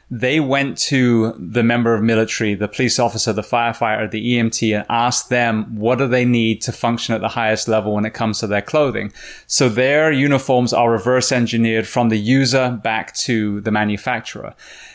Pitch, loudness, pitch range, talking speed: 115 Hz, -17 LUFS, 110-125 Hz, 185 wpm